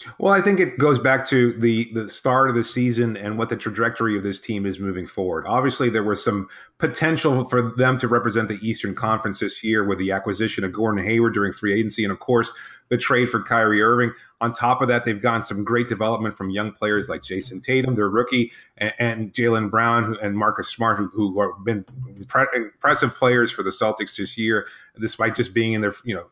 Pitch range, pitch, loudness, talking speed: 105-120 Hz, 115 Hz, -21 LUFS, 220 wpm